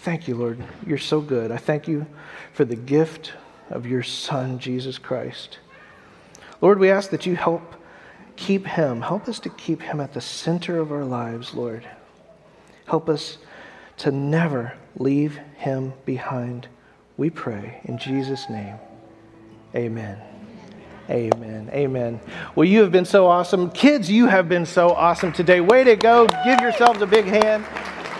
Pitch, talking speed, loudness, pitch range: 155 Hz, 155 wpm, -20 LUFS, 125-190 Hz